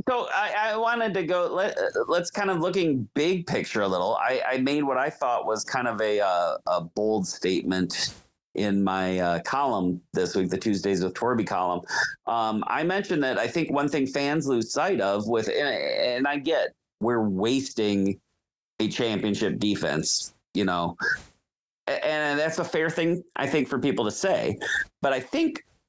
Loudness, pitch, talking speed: -26 LUFS, 140 Hz, 185 wpm